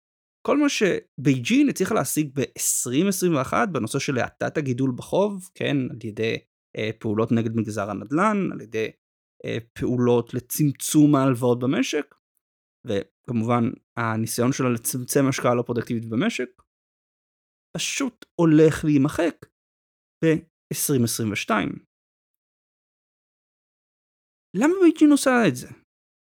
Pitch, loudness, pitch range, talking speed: 135 Hz, -23 LUFS, 115-160 Hz, 100 wpm